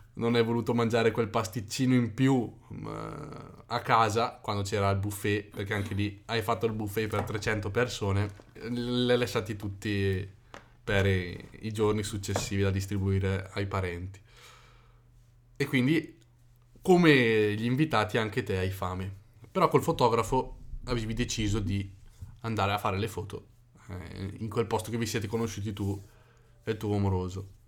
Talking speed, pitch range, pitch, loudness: 150 wpm, 100-120 Hz, 110 Hz, -29 LUFS